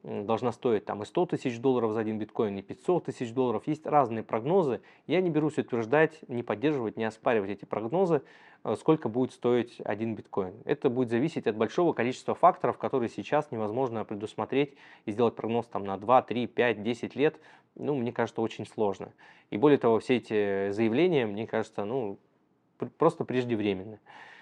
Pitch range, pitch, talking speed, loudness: 110-135 Hz, 120 Hz, 170 wpm, -29 LUFS